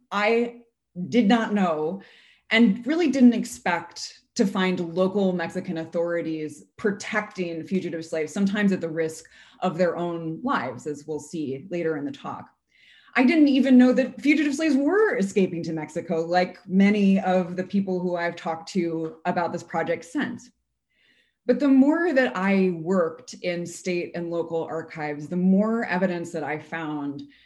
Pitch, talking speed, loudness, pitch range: 180 Hz, 155 wpm, -24 LUFS, 165-215 Hz